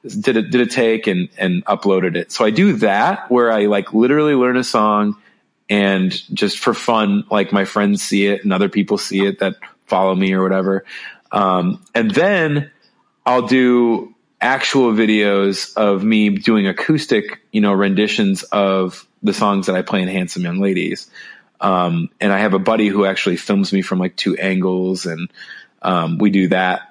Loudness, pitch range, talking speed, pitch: -16 LUFS, 95-115 Hz, 185 wpm, 100 Hz